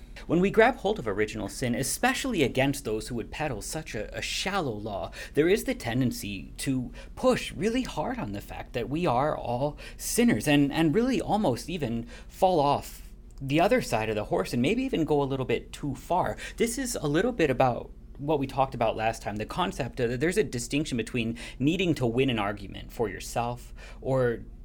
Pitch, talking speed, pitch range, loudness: 135 Hz, 200 wpm, 115-165 Hz, -28 LUFS